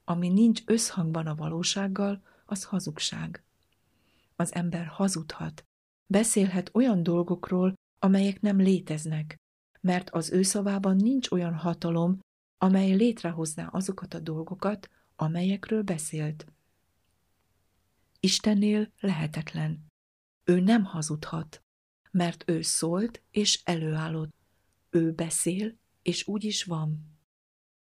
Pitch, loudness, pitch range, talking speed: 175 Hz, -28 LUFS, 155-195 Hz, 100 wpm